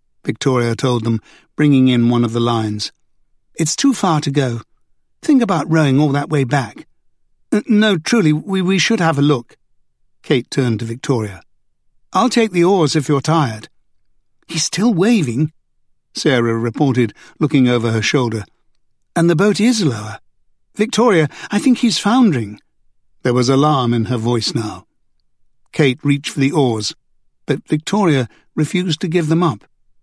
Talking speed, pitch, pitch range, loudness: 160 wpm, 145 Hz, 120-170 Hz, -16 LUFS